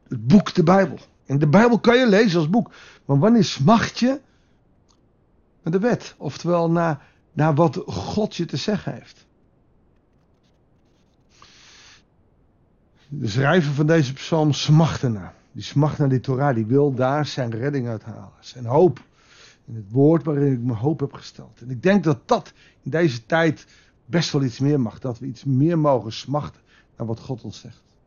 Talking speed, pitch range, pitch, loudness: 175 wpm, 125-165 Hz, 140 Hz, -20 LUFS